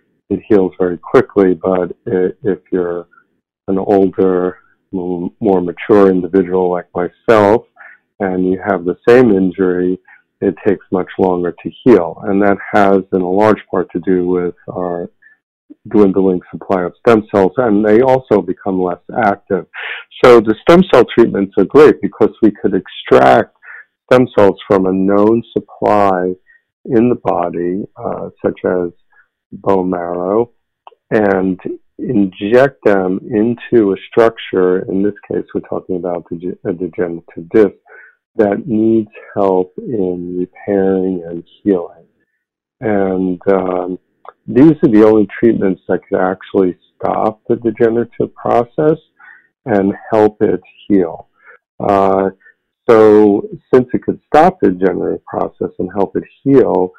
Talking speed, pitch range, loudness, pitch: 135 wpm, 90-105 Hz, -14 LUFS, 95 Hz